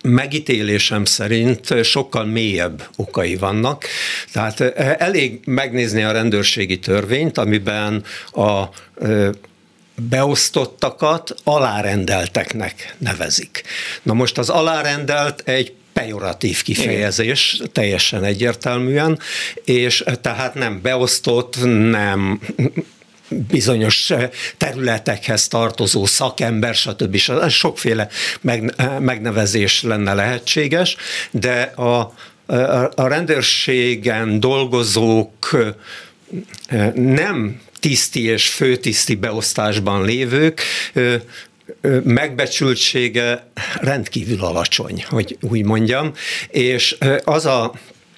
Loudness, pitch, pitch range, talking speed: -17 LUFS, 120 Hz, 110-130 Hz, 75 wpm